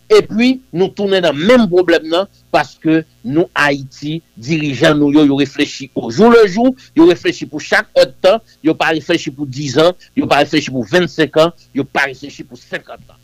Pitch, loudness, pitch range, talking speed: 160 Hz, -13 LUFS, 145-190 Hz, 200 wpm